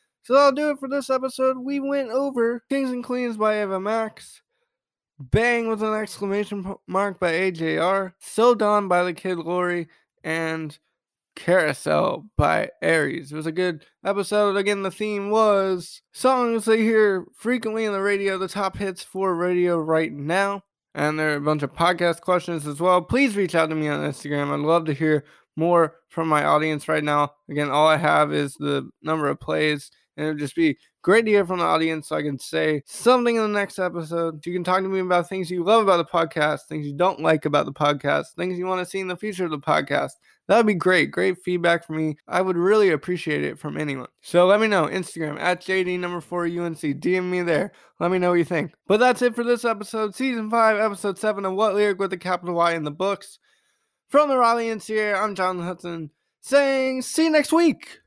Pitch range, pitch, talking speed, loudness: 165-215 Hz, 185 Hz, 215 wpm, -22 LUFS